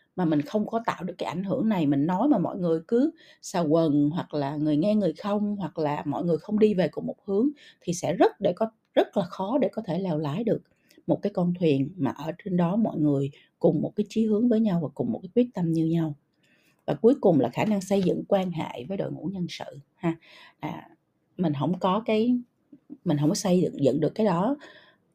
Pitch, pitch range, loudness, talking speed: 180 Hz, 155-215 Hz, -26 LUFS, 245 wpm